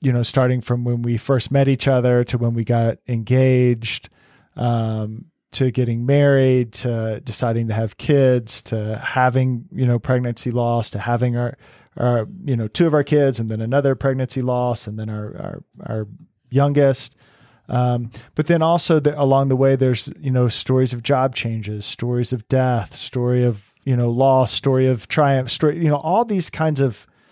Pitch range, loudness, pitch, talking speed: 115-135 Hz, -19 LUFS, 125 Hz, 185 wpm